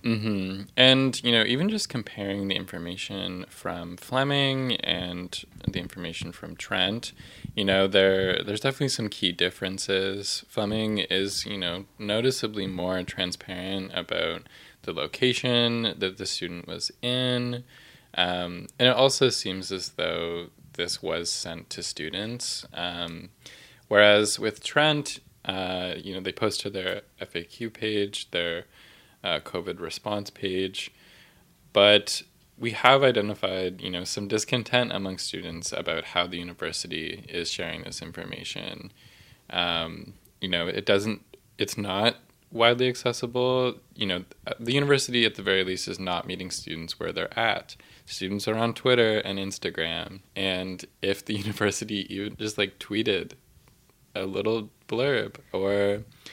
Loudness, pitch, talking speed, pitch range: -26 LUFS, 100 Hz, 140 wpm, 90-115 Hz